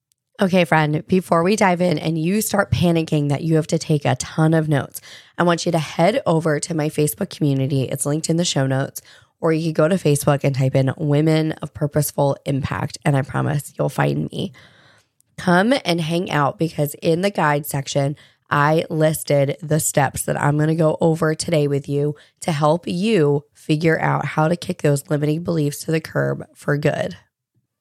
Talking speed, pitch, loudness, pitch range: 200 wpm, 150 Hz, -20 LUFS, 140-165 Hz